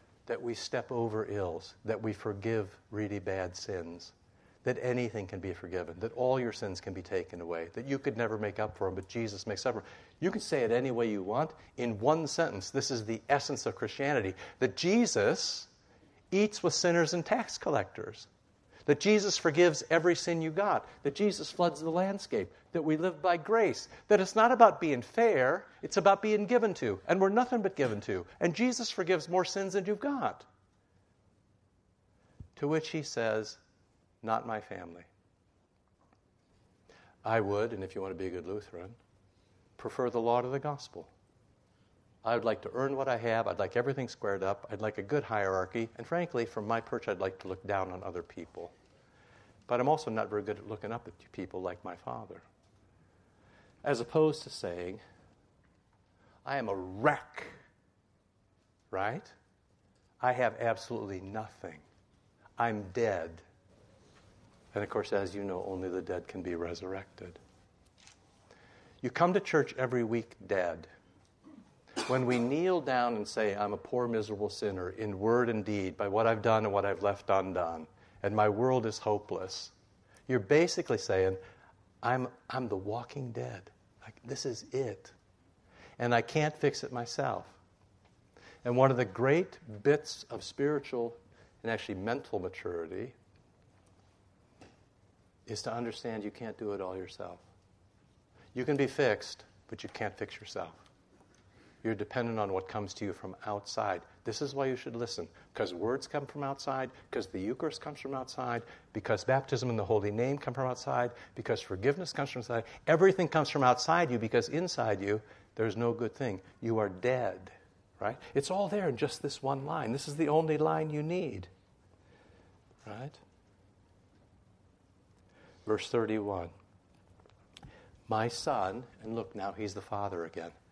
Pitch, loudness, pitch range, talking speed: 110 Hz, -33 LUFS, 95-135 Hz, 170 wpm